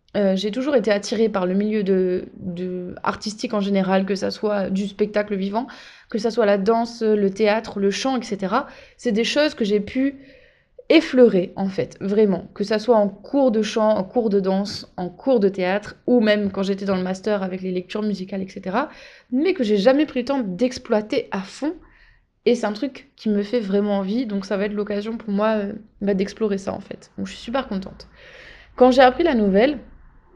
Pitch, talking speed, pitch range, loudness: 210 Hz, 210 wpm, 200-250 Hz, -21 LUFS